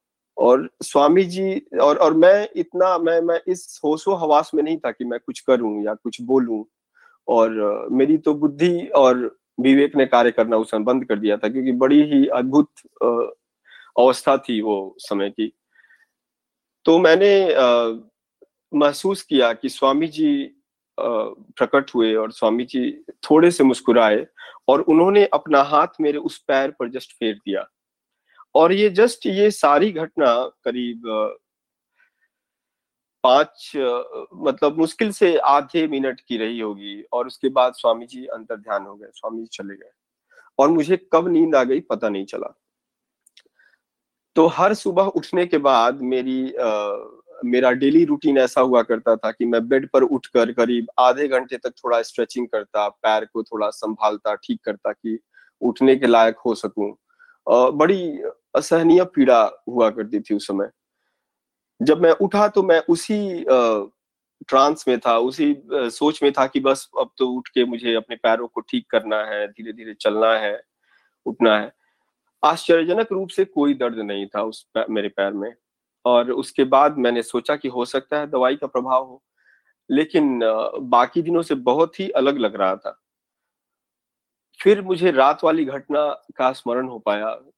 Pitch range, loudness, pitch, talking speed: 115-175 Hz, -19 LUFS, 130 Hz, 155 wpm